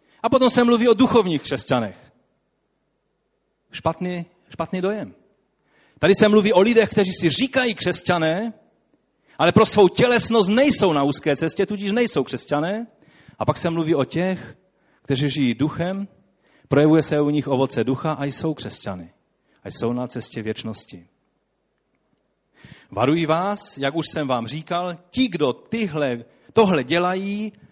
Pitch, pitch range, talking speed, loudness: 165 Hz, 140-205 Hz, 140 wpm, -20 LUFS